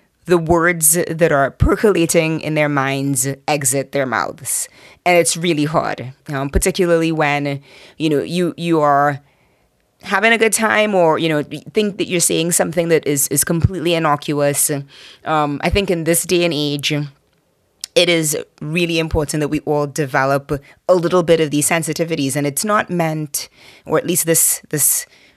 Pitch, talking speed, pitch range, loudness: 155 Hz, 170 wpm, 145-175 Hz, -16 LUFS